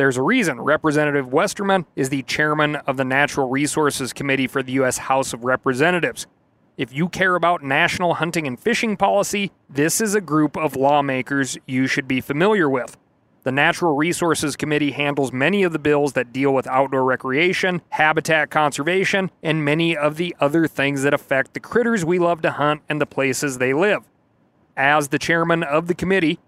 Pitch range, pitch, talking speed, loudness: 135-170 Hz, 150 Hz, 180 wpm, -19 LUFS